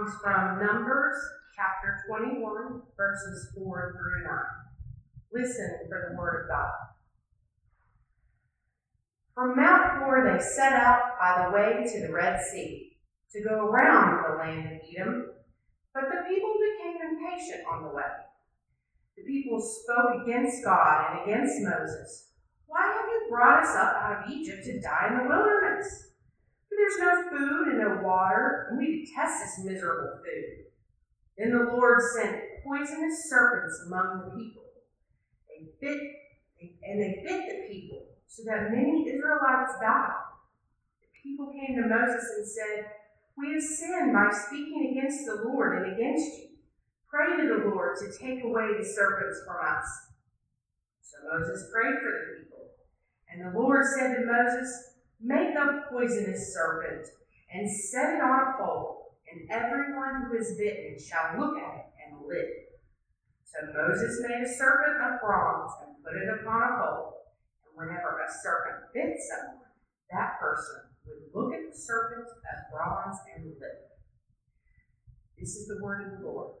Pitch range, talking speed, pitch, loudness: 210-295 Hz, 155 wpm, 245 Hz, -28 LUFS